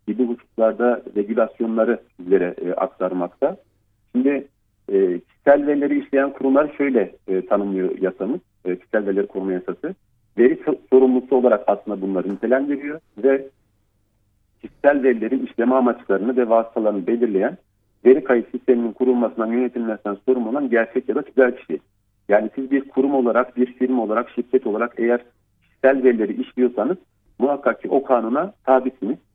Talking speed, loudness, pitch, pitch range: 135 wpm, -20 LUFS, 120 Hz, 105-130 Hz